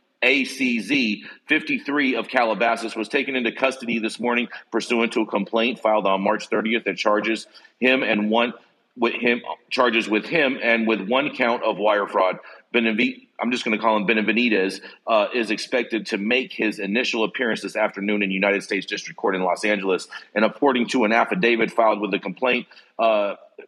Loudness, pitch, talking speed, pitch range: -21 LUFS, 115 Hz, 180 wpm, 105-125 Hz